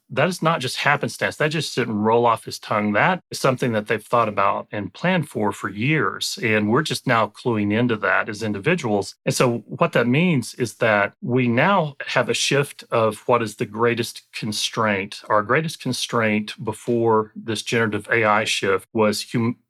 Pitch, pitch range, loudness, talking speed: 115 Hz, 110-130 Hz, -21 LUFS, 185 wpm